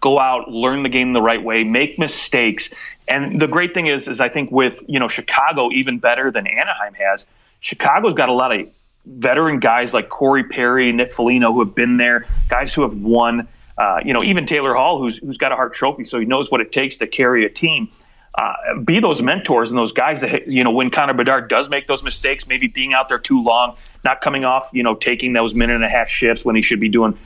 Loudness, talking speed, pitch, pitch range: -16 LUFS, 240 wpm, 125 Hz, 115-135 Hz